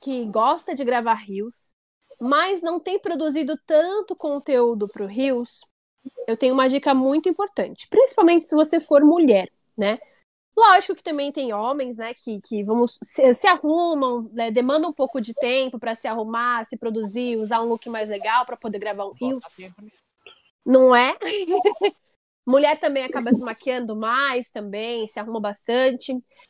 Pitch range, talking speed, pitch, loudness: 230-305 Hz, 160 wpm, 255 Hz, -21 LUFS